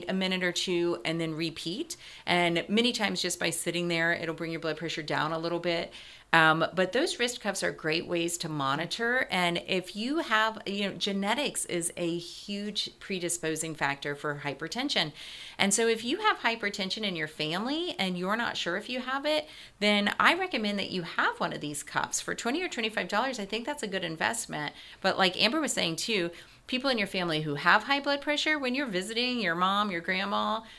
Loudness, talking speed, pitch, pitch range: -29 LUFS, 210 wpm, 190 Hz, 170-230 Hz